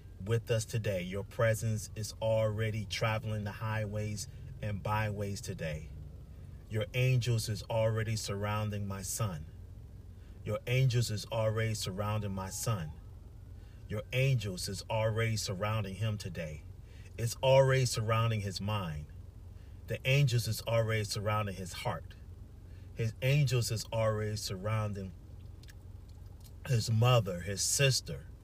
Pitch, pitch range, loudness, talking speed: 105 Hz, 95-115 Hz, -33 LUFS, 115 wpm